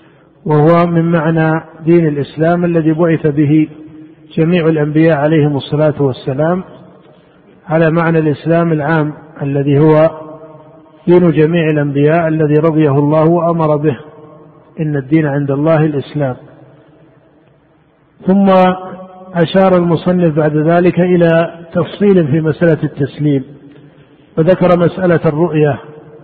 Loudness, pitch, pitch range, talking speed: -12 LUFS, 155 Hz, 150-165 Hz, 105 wpm